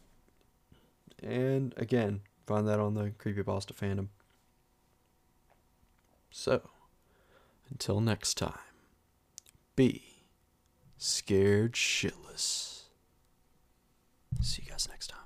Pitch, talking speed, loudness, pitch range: 105 Hz, 85 wpm, -33 LUFS, 95-120 Hz